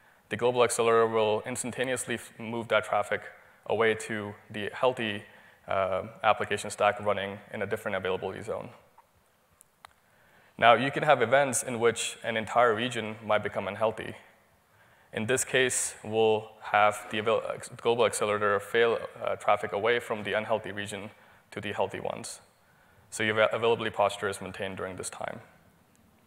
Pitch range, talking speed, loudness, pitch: 105-125 Hz, 145 wpm, -28 LUFS, 115 Hz